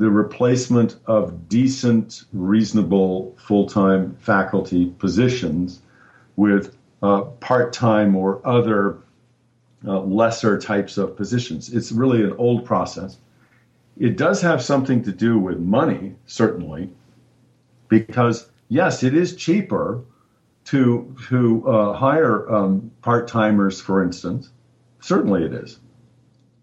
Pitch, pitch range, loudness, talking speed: 115 Hz, 100-125 Hz, -19 LUFS, 105 wpm